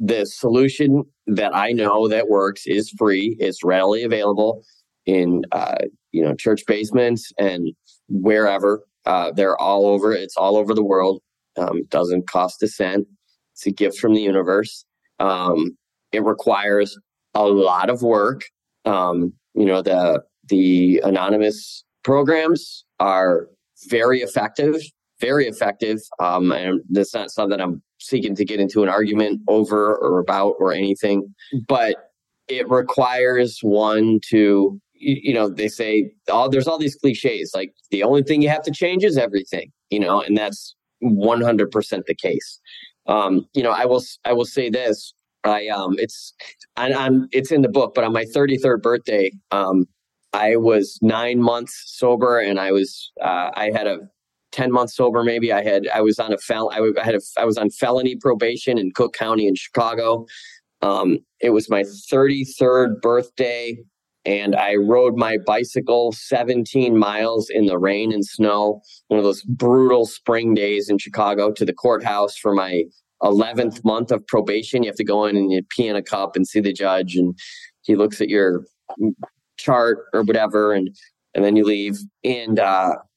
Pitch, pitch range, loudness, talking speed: 110 Hz, 100-125 Hz, -19 LUFS, 170 wpm